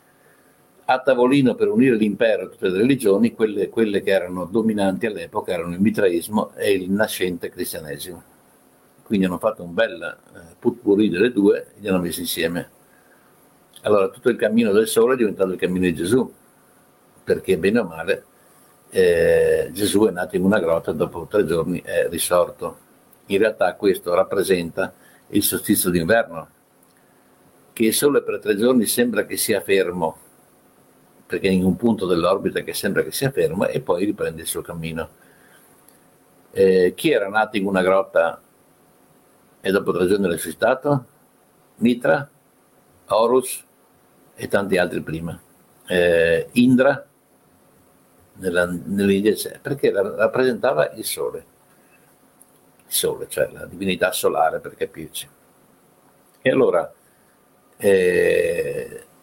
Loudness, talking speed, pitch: -20 LUFS, 135 wpm, 110 Hz